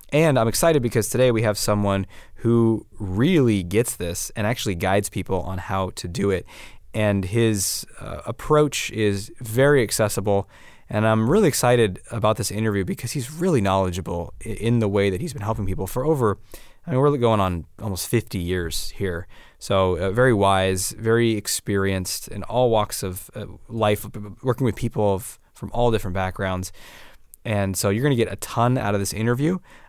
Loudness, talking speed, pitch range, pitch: -22 LUFS, 175 wpm, 95-120 Hz, 105 Hz